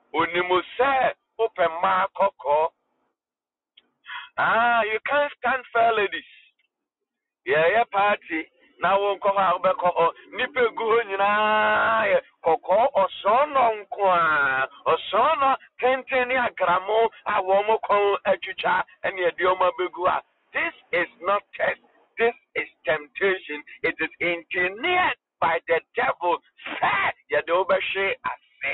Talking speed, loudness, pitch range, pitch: 110 wpm, -23 LUFS, 185-255 Hz, 205 Hz